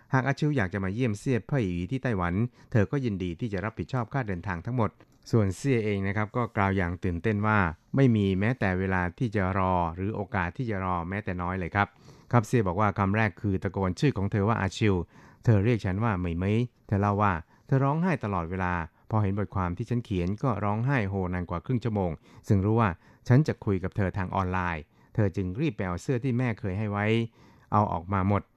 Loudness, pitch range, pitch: -28 LUFS, 95-120 Hz, 105 Hz